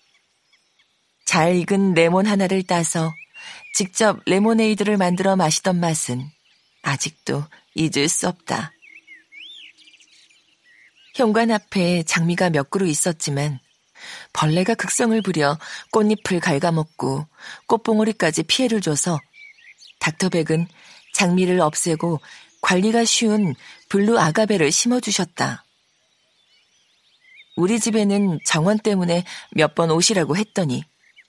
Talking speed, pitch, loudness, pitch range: 230 characters per minute, 180 Hz, -20 LUFS, 160-210 Hz